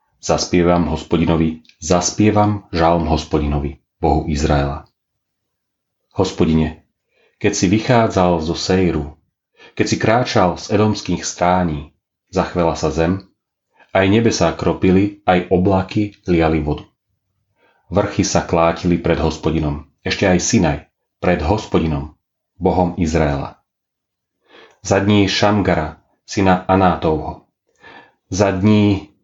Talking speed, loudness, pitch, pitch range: 100 wpm, -17 LUFS, 90 Hz, 80-100 Hz